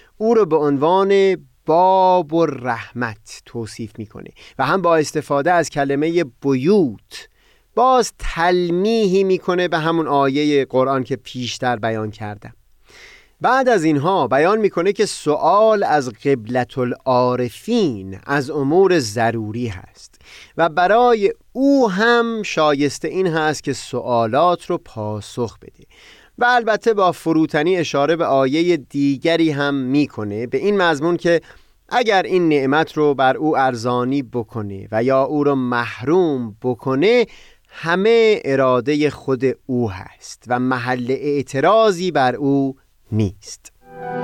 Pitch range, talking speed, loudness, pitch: 125-180 Hz, 125 wpm, -18 LUFS, 145 Hz